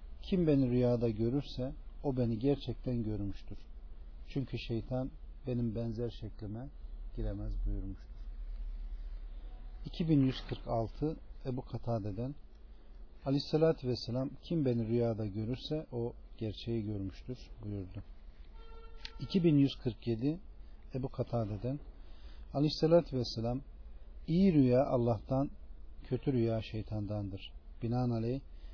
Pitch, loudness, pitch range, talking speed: 115 Hz, -35 LUFS, 100-130 Hz, 90 wpm